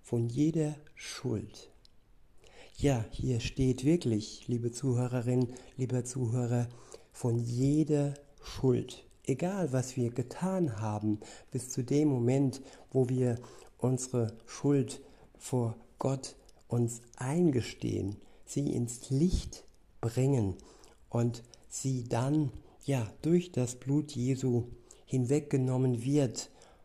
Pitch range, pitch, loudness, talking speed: 120-140 Hz, 125 Hz, -32 LUFS, 100 wpm